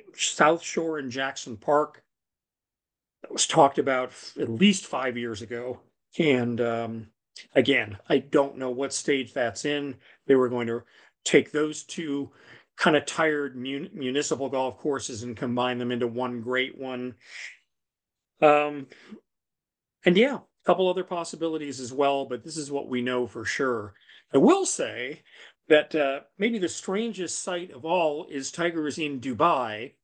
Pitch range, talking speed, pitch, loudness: 125-155 Hz, 160 wpm, 140 Hz, -26 LUFS